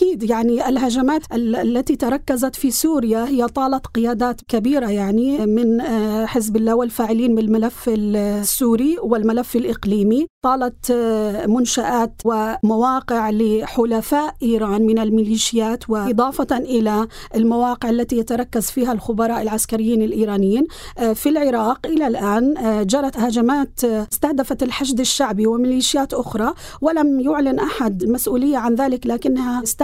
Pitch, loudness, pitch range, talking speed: 235 Hz, -18 LUFS, 225-260 Hz, 110 wpm